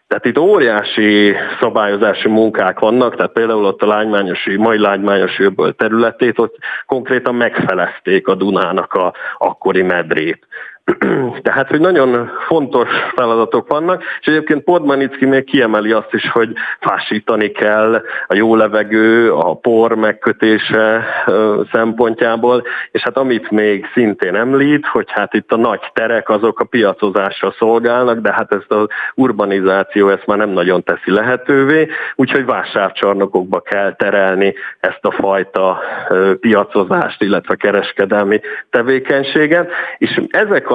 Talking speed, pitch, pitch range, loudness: 125 wpm, 110 Hz, 100-125 Hz, -13 LUFS